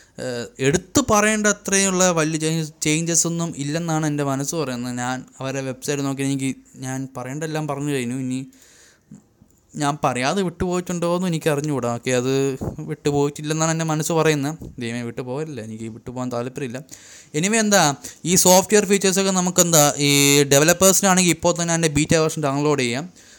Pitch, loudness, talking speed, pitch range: 150 Hz, -20 LUFS, 135 wpm, 135-170 Hz